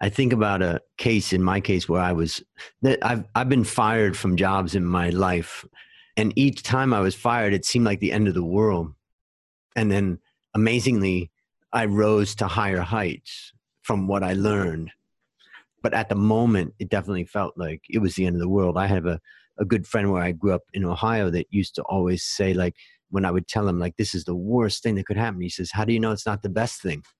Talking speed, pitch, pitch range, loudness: 230 wpm, 100 Hz, 90-110 Hz, -23 LUFS